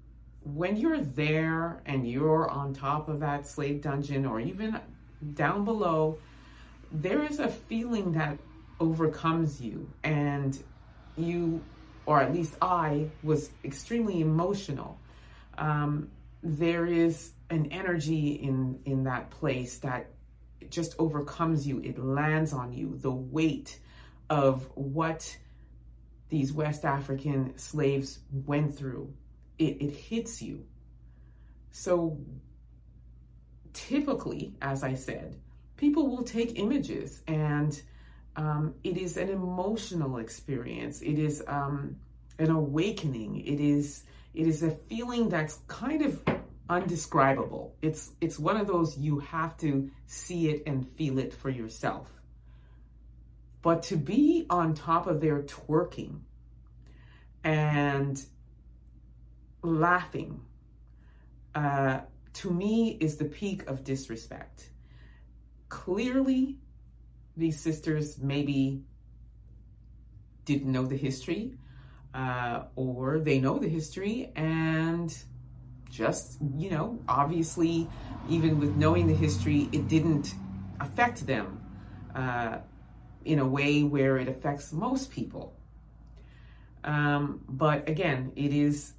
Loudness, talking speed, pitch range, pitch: -30 LUFS, 115 wpm, 125-160 Hz, 145 Hz